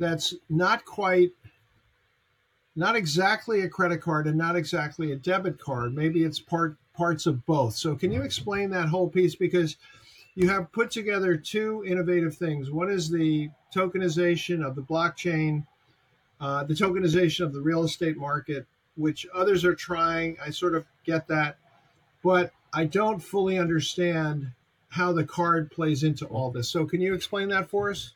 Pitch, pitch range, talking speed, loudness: 165 Hz, 150-180 Hz, 165 wpm, -26 LUFS